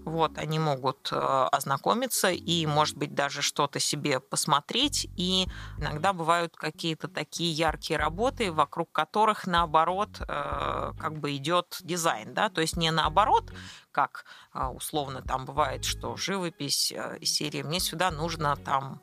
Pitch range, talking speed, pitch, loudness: 150-180 Hz, 130 wpm, 165 Hz, -28 LUFS